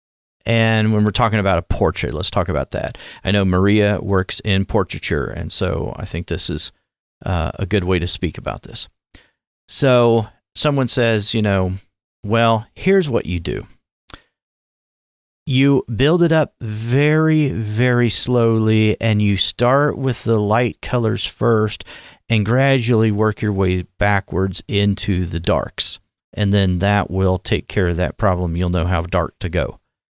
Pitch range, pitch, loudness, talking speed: 95-115 Hz, 105 Hz, -18 LUFS, 160 wpm